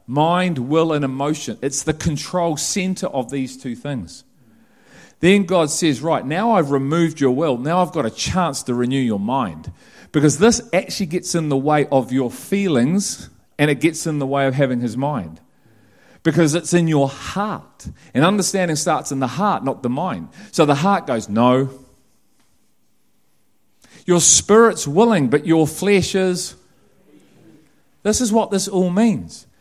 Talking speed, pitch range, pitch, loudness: 165 wpm, 135-185 Hz, 160 Hz, -18 LUFS